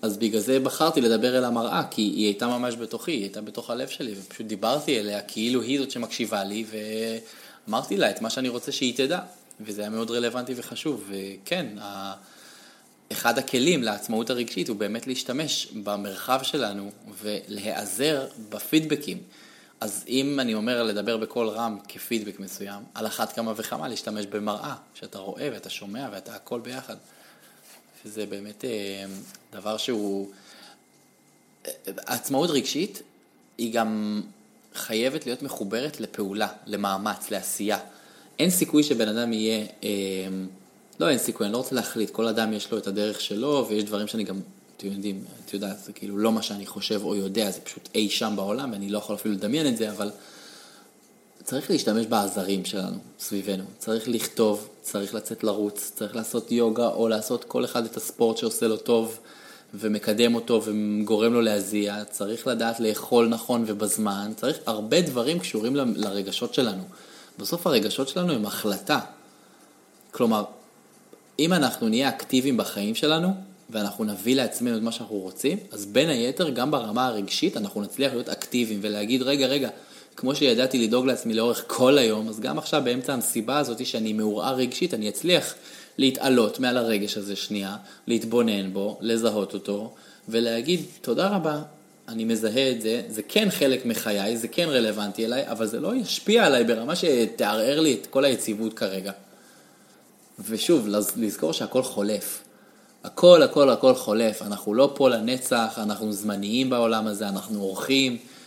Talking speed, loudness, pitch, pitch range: 155 wpm, -25 LUFS, 110 Hz, 105-120 Hz